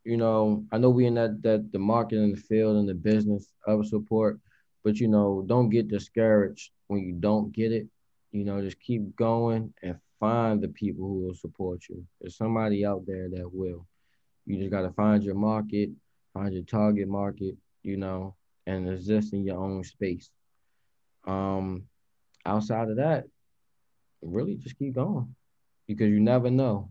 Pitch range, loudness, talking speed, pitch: 95-110 Hz, -28 LUFS, 175 wpm, 105 Hz